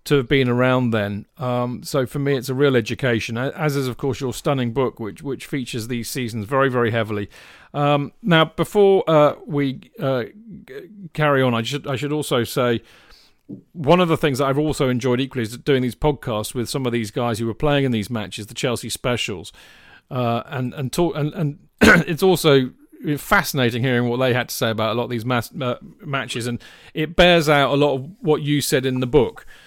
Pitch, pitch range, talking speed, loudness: 135 Hz, 120-150 Hz, 215 wpm, -20 LUFS